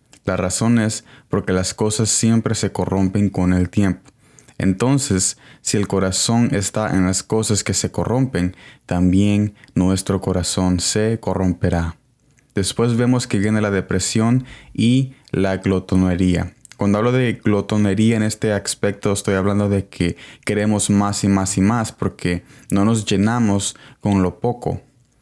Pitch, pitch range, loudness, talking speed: 100 Hz, 95-115 Hz, -19 LUFS, 145 wpm